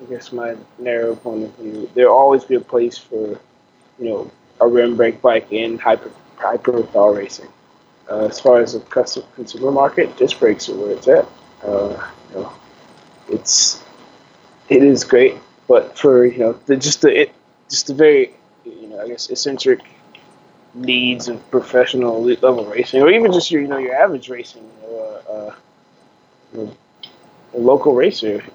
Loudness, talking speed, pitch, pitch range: -15 LUFS, 180 wpm, 125 Hz, 115-150 Hz